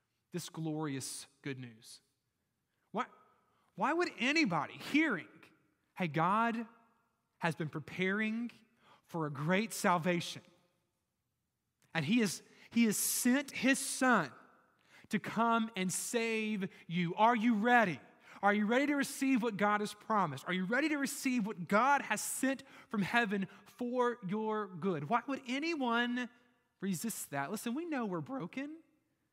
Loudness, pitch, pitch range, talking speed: -34 LUFS, 215 Hz, 175-245 Hz, 135 wpm